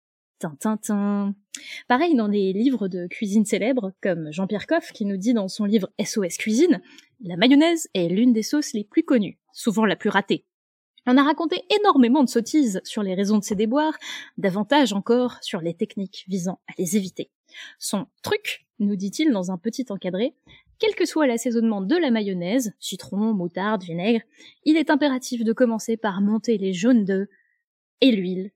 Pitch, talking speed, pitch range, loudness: 220 Hz, 175 wpm, 200-275 Hz, -23 LUFS